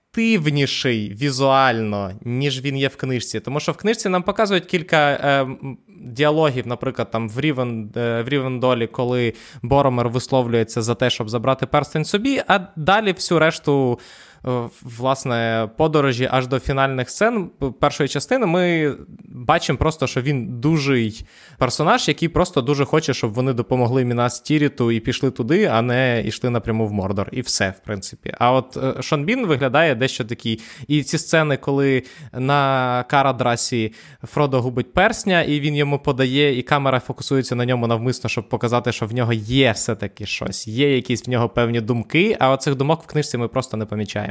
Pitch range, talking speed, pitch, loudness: 120-145 Hz, 165 wpm, 130 Hz, -20 LUFS